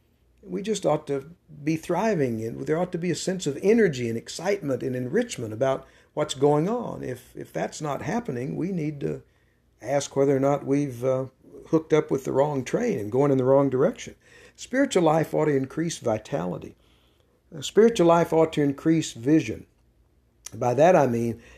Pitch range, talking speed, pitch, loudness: 130-170 Hz, 180 wpm, 145 Hz, -25 LUFS